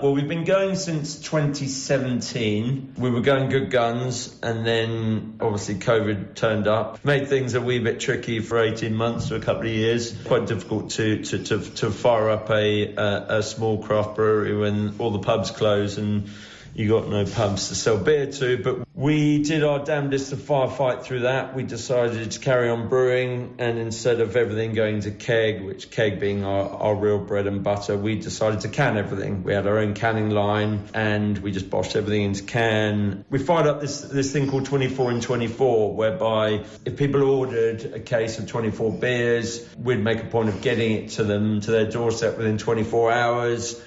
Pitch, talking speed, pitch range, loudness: 115 Hz, 195 wpm, 105-130 Hz, -23 LUFS